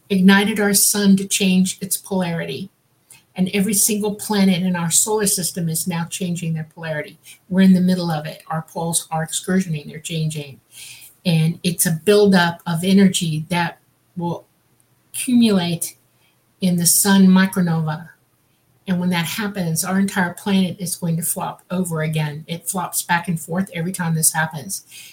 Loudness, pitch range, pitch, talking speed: -19 LUFS, 165-190 Hz, 175 Hz, 160 wpm